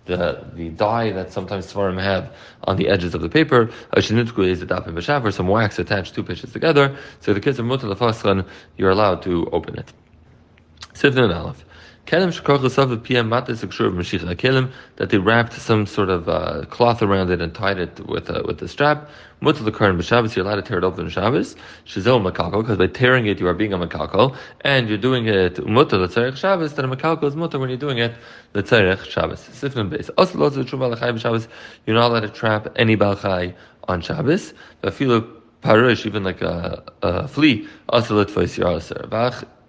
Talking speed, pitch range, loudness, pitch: 175 wpm, 95-125 Hz, -20 LUFS, 110 Hz